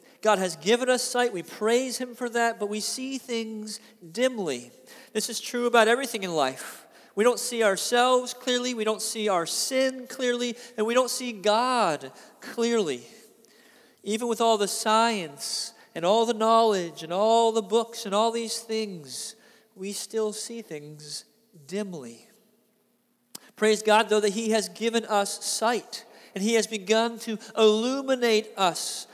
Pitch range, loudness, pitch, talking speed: 215-235 Hz, -25 LUFS, 225 Hz, 160 wpm